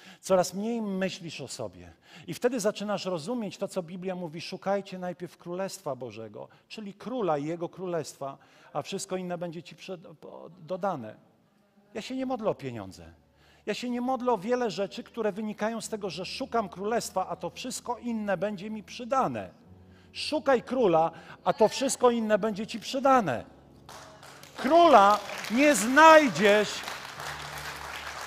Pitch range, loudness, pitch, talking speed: 175-230 Hz, -27 LUFS, 195 Hz, 145 wpm